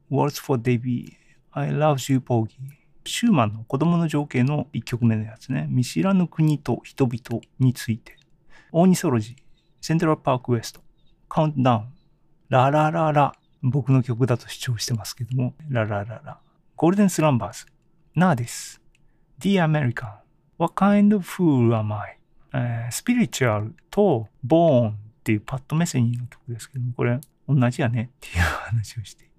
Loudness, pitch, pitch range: -23 LUFS, 135 Hz, 120-160 Hz